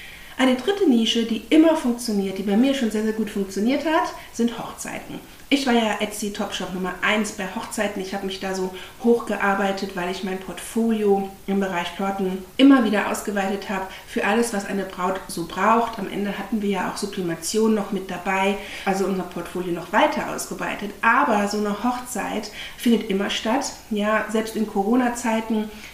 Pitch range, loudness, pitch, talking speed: 195-230 Hz, -23 LUFS, 205 Hz, 175 wpm